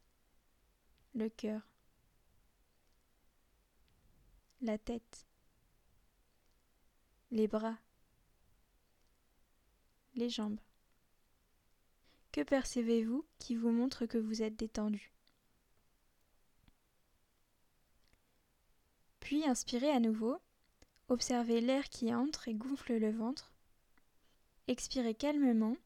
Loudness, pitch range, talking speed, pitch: -37 LUFS, 225-260 Hz, 70 wpm, 235 Hz